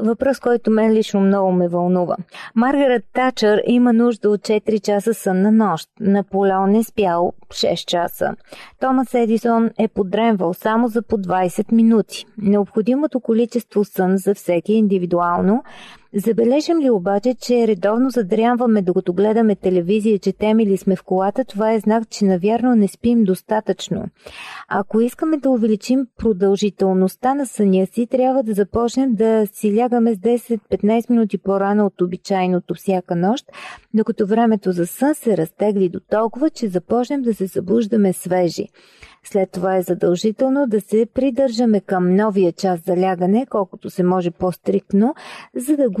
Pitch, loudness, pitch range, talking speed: 215 Hz, -18 LUFS, 190-235 Hz, 150 wpm